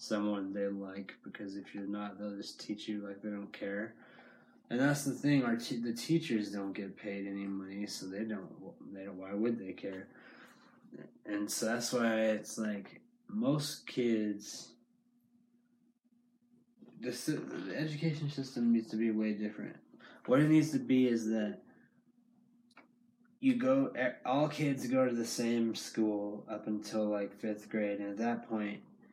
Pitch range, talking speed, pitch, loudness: 105-160 Hz, 165 wpm, 115 Hz, -35 LUFS